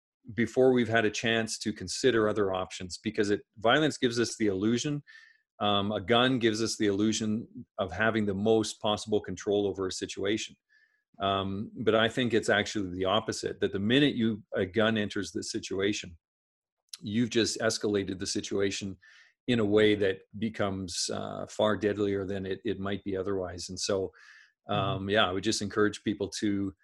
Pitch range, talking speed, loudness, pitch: 100-115 Hz, 175 wpm, -29 LUFS, 105 Hz